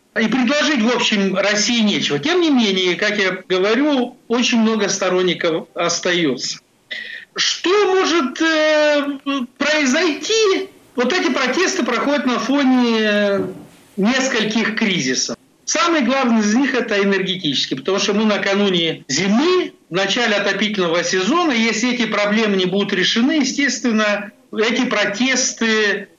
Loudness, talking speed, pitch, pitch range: -17 LUFS, 120 wpm, 230 Hz, 200-285 Hz